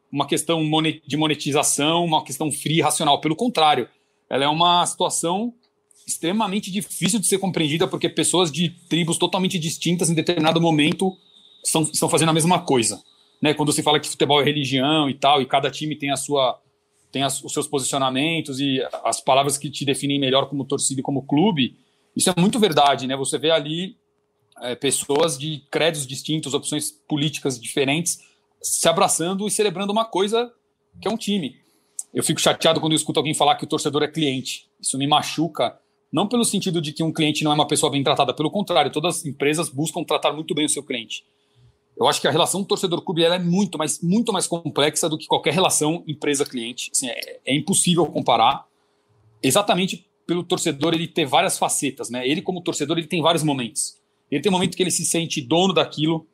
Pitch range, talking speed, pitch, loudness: 145-175 Hz, 190 wpm, 155 Hz, -21 LUFS